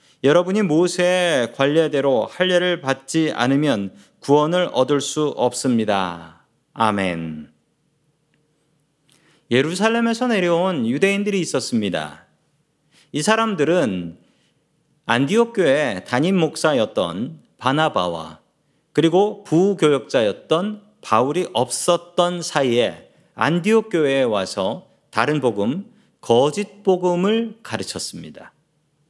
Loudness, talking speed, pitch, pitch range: -19 LUFS, 230 characters per minute, 155 Hz, 140-185 Hz